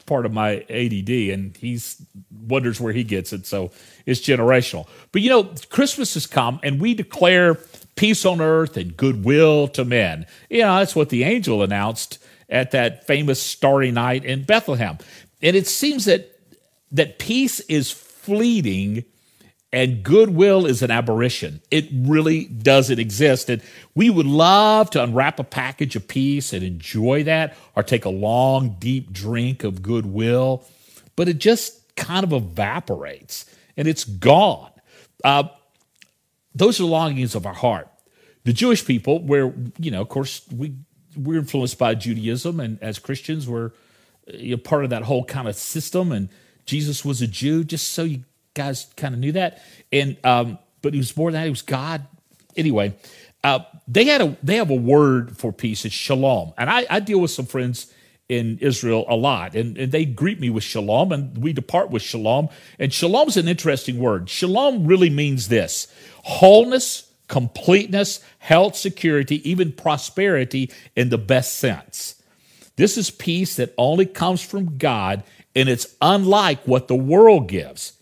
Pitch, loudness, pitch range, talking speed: 135 Hz, -19 LUFS, 120-165 Hz, 170 wpm